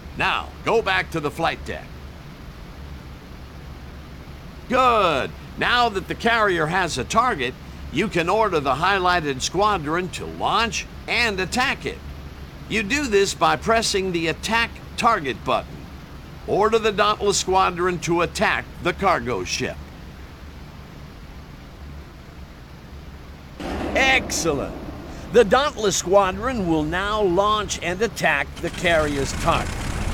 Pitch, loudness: 170 Hz, -21 LUFS